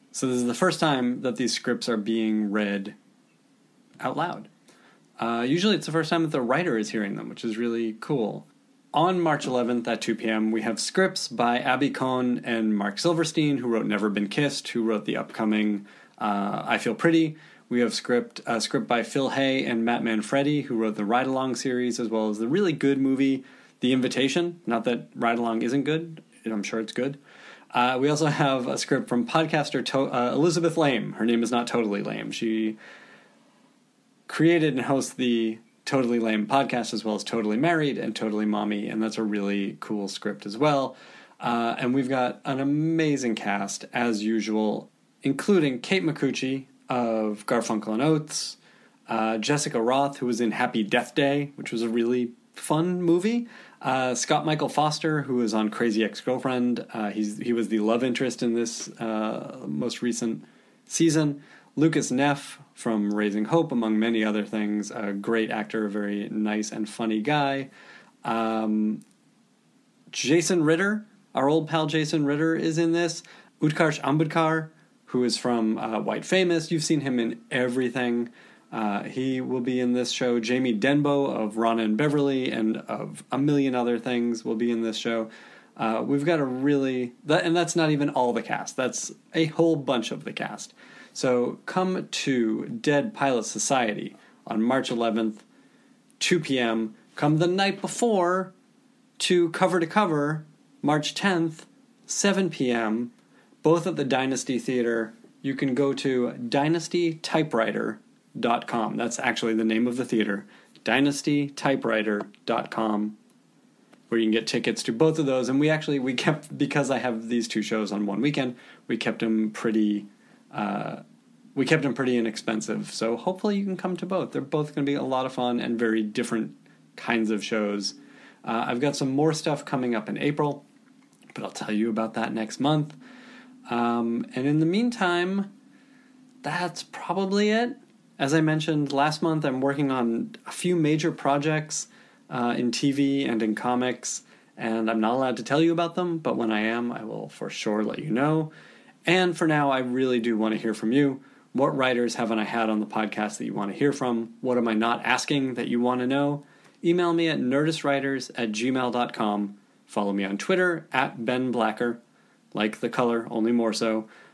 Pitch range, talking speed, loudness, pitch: 115-155 Hz, 180 wpm, -26 LUFS, 125 Hz